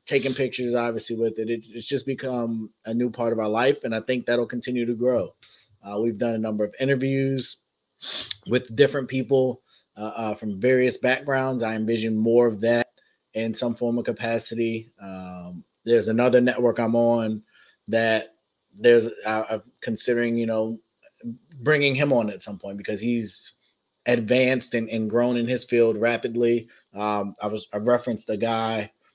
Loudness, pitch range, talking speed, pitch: -24 LUFS, 110-125 Hz, 170 wpm, 115 Hz